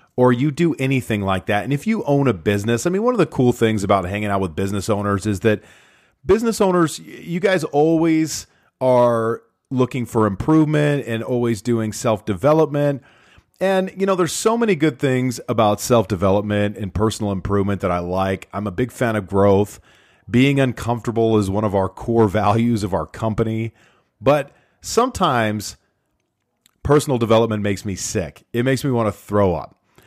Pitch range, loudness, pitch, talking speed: 105-140 Hz, -19 LUFS, 115 Hz, 175 wpm